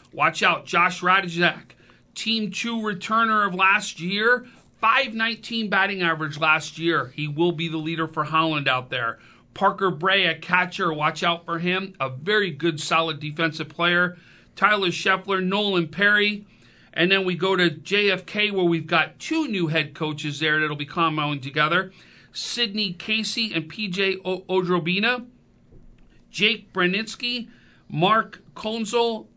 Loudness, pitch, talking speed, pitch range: -22 LUFS, 185 Hz, 140 wpm, 165-210 Hz